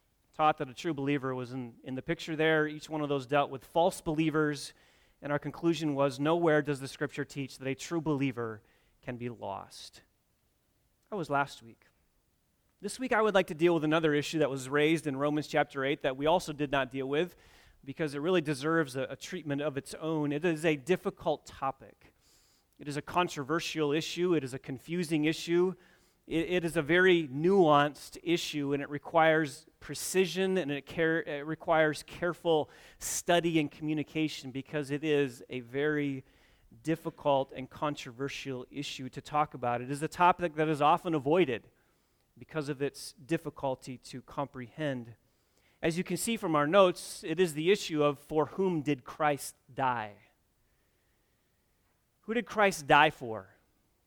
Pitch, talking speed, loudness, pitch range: 150 Hz, 170 wpm, -31 LUFS, 135-165 Hz